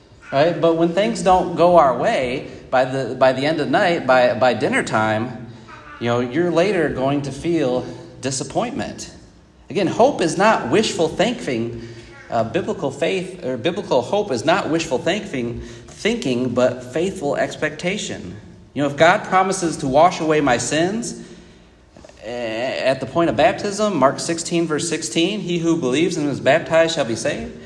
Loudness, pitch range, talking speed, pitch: -19 LUFS, 125-170 Hz, 165 wpm, 155 Hz